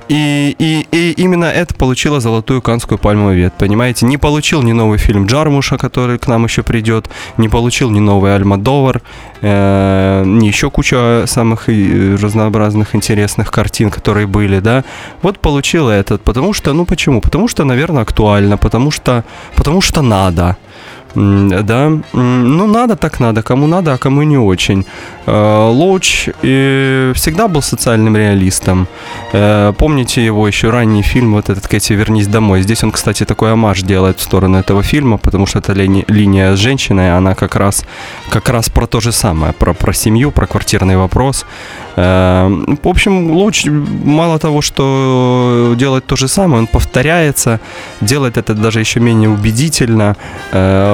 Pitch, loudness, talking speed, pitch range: 115 Hz, -11 LUFS, 155 wpm, 100-135 Hz